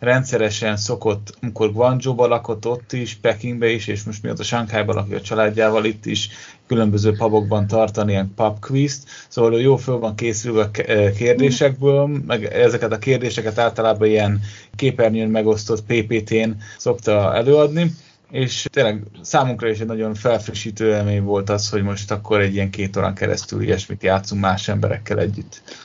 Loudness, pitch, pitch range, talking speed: -19 LUFS, 110 Hz, 105-120 Hz, 145 wpm